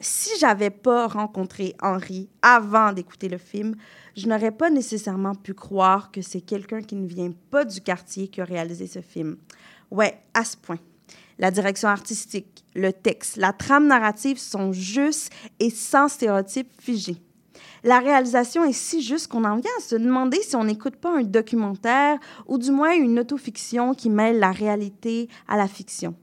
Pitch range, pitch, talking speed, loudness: 195-250 Hz, 215 Hz, 175 wpm, -22 LUFS